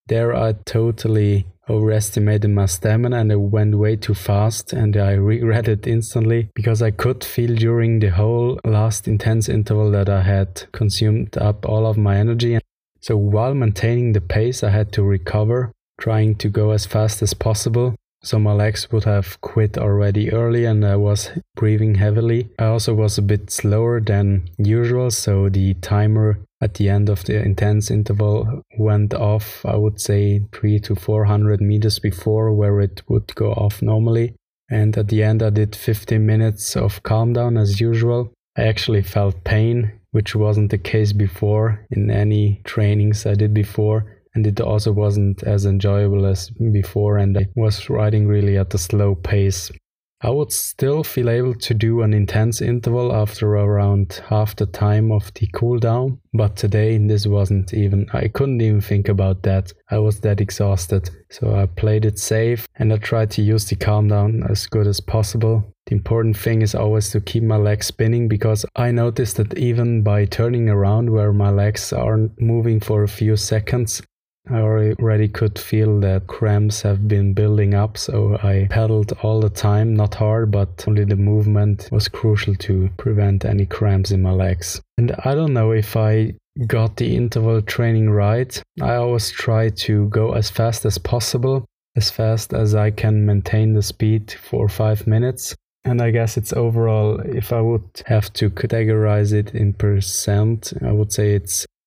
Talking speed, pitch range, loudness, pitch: 175 wpm, 105-115 Hz, -18 LUFS, 105 Hz